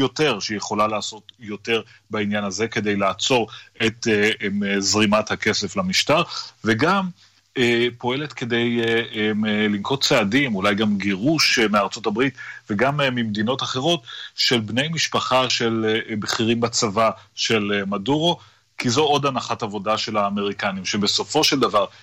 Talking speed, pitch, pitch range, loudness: 140 wpm, 110 Hz, 105-120 Hz, -21 LUFS